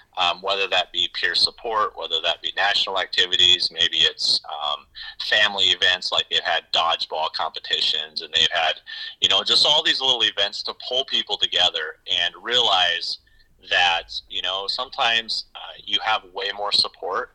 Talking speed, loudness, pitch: 165 wpm, -20 LUFS, 385 Hz